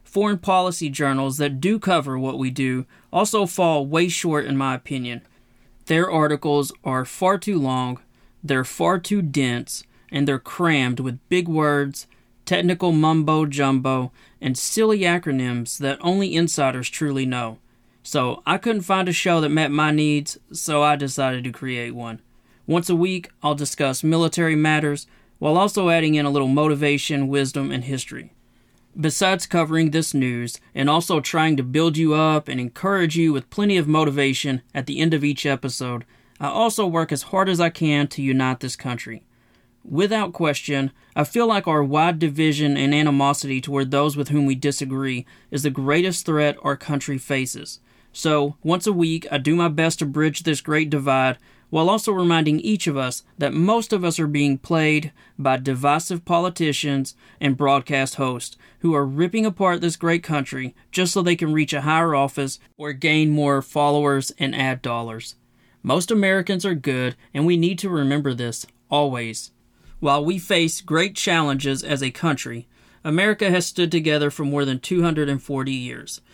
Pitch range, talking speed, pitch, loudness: 135-165 Hz, 170 wpm, 150 Hz, -21 LUFS